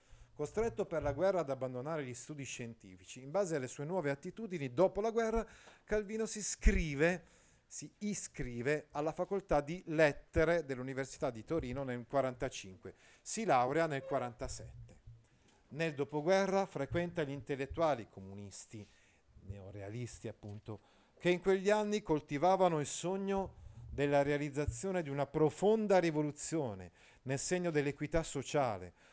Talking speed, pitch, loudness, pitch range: 125 wpm, 145 Hz, -36 LUFS, 125-180 Hz